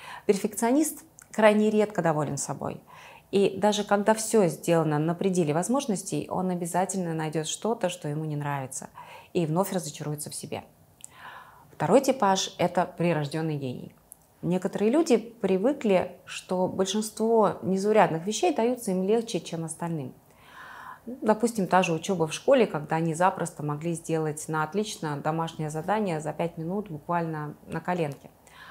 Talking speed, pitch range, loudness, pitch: 135 wpm, 160-215 Hz, -27 LUFS, 180 Hz